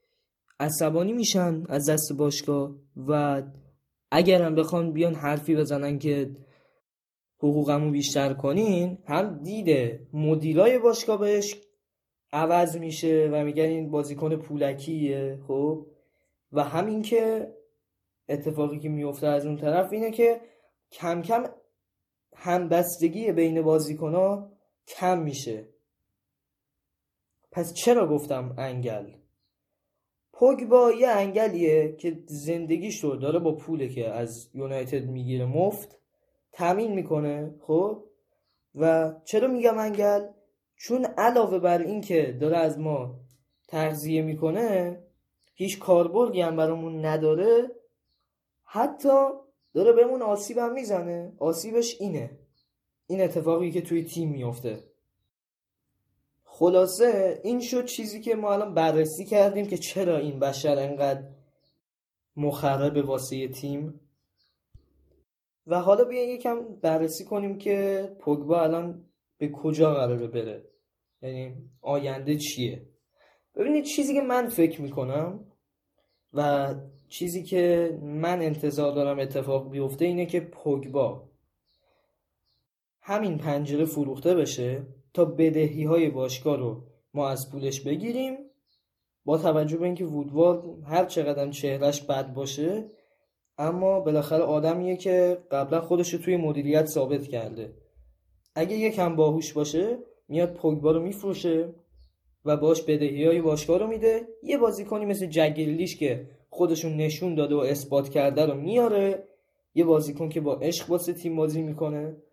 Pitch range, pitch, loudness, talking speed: 145-185 Hz, 160 Hz, -26 LUFS, 120 wpm